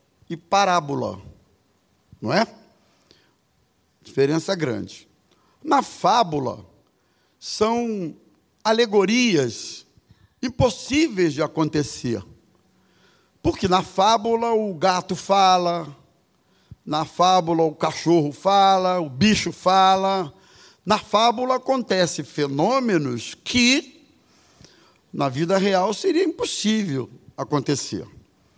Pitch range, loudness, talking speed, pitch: 150-215 Hz, -21 LUFS, 85 wpm, 185 Hz